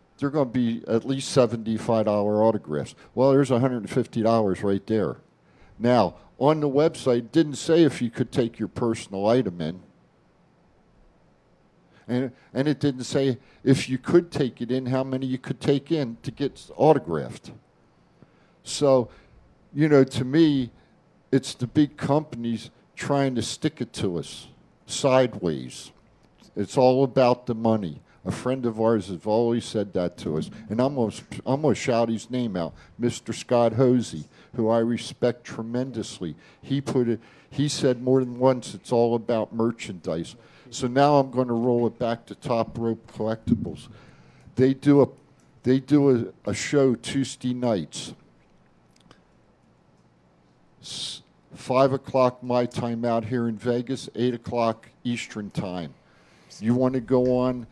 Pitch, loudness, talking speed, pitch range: 125 Hz, -24 LUFS, 155 wpm, 115-135 Hz